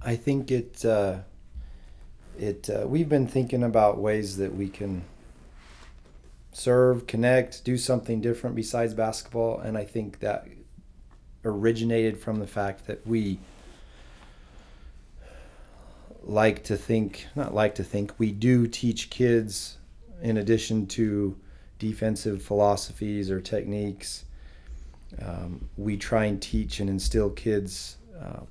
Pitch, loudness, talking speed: 105 Hz, -27 LUFS, 120 wpm